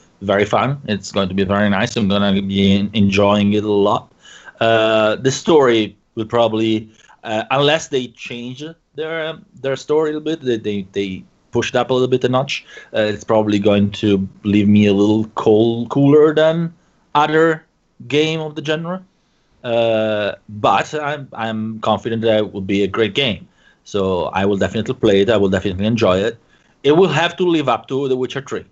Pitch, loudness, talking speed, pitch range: 110 Hz, -17 LUFS, 195 wpm, 105-140 Hz